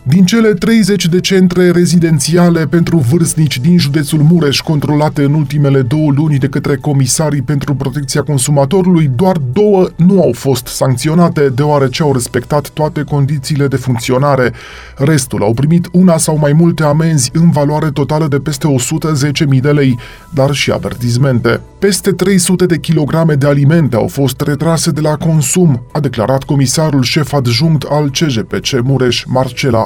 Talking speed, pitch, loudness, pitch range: 150 wpm, 150 Hz, -11 LUFS, 135-165 Hz